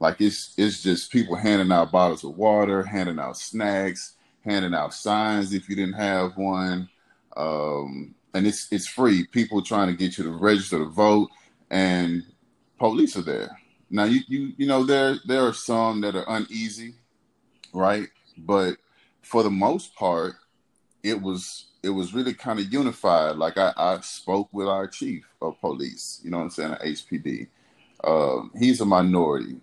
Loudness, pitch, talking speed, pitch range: -24 LUFS, 100 Hz, 170 wpm, 90-110 Hz